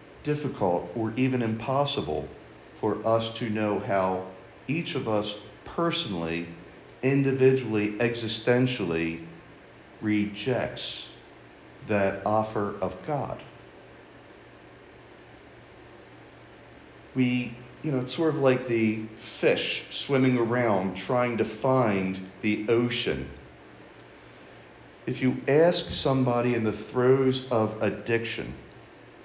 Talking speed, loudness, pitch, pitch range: 90 wpm, -27 LUFS, 115 Hz, 105-130 Hz